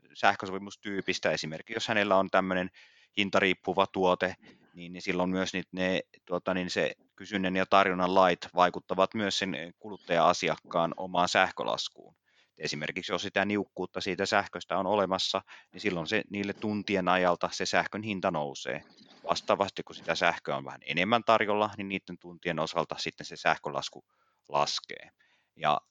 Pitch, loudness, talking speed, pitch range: 95 Hz, -30 LUFS, 140 wpm, 90-100 Hz